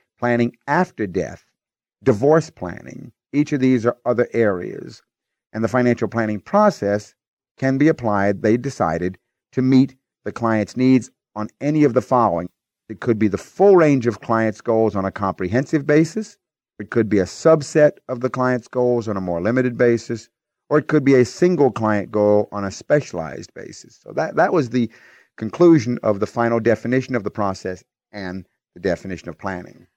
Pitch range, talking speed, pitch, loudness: 105-135 Hz, 175 wpm, 120 Hz, -19 LUFS